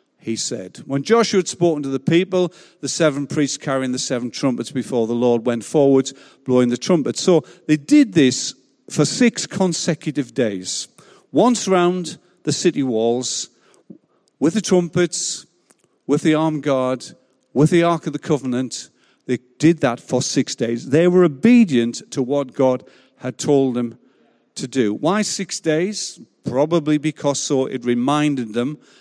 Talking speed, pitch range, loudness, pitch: 155 wpm, 125-170 Hz, -19 LUFS, 145 Hz